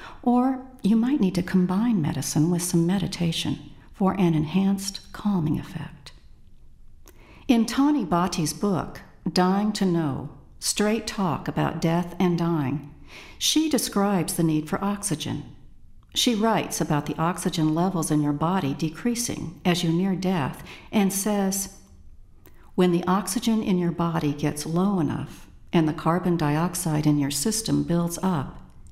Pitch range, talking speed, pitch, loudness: 155-195 Hz, 140 wpm, 175 Hz, -24 LUFS